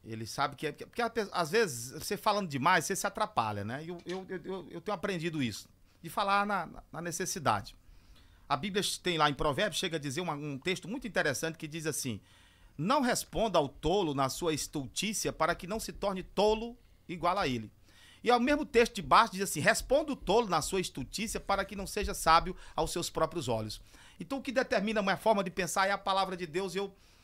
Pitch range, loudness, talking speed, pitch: 145-205 Hz, -32 LUFS, 220 wpm, 180 Hz